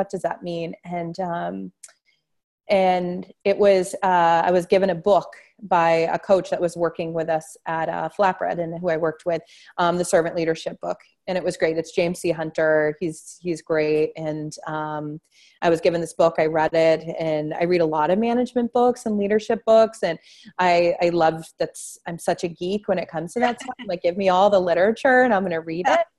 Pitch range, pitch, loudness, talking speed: 160-195 Hz, 175 Hz, -22 LUFS, 215 wpm